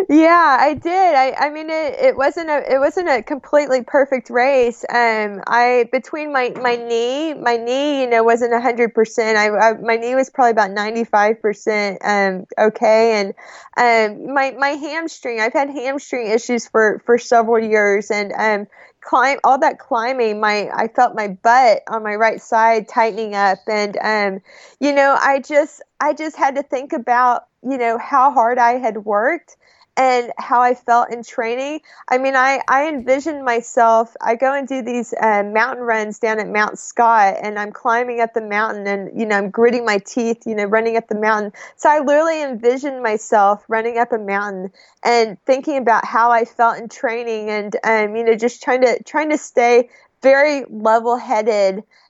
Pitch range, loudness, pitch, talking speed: 220-265 Hz, -16 LUFS, 235 Hz, 185 wpm